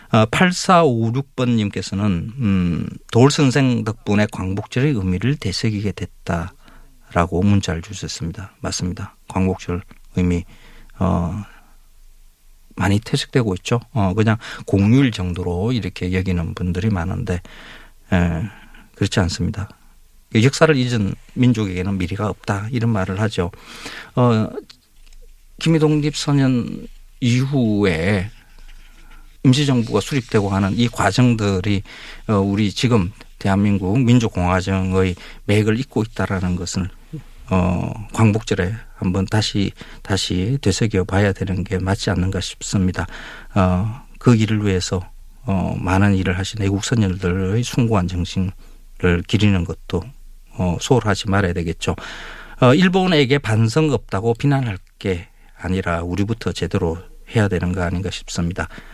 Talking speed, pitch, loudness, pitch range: 265 characters per minute, 100 Hz, -19 LUFS, 90-115 Hz